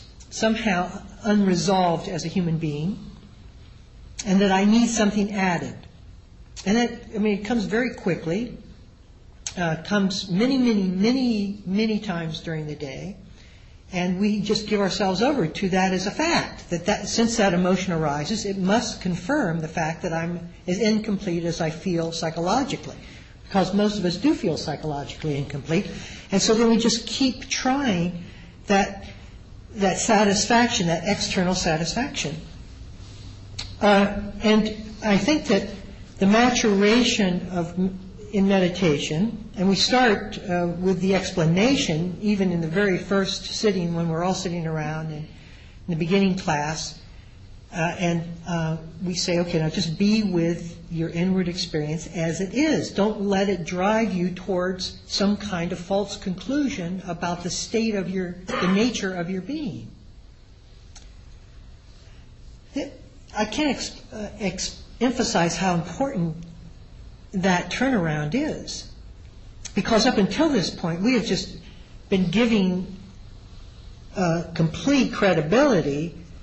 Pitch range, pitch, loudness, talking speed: 165-210 Hz, 185 Hz, -23 LUFS, 140 wpm